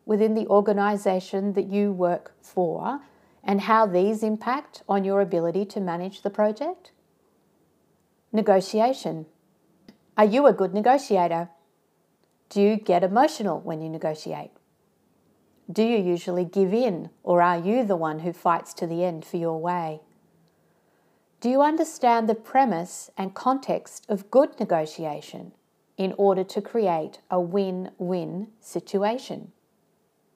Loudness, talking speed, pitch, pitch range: -24 LUFS, 130 wpm, 195 Hz, 175-220 Hz